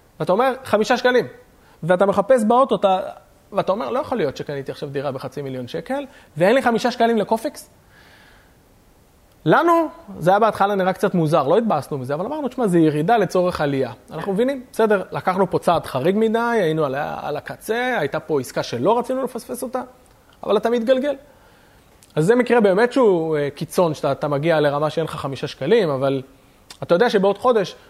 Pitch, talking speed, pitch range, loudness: 195 Hz, 180 wpm, 150-245 Hz, -20 LUFS